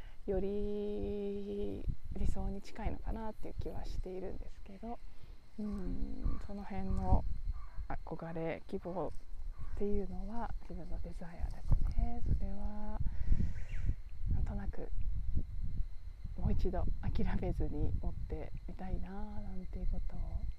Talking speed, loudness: 240 characters per minute, -42 LUFS